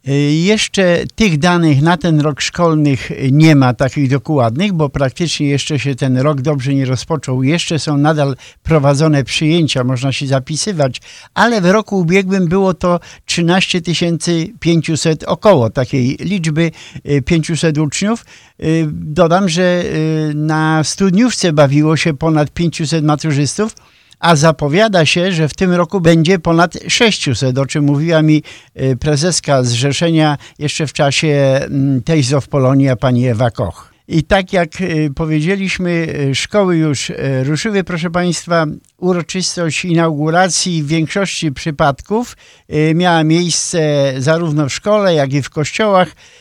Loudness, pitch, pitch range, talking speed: -14 LUFS, 160 Hz, 145-175 Hz, 125 wpm